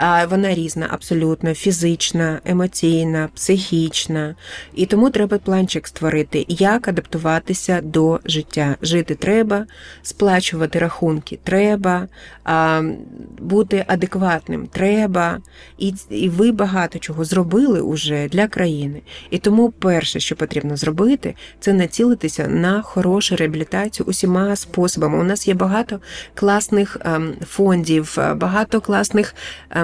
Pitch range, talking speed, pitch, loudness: 160-200 Hz, 105 wpm, 180 Hz, -18 LUFS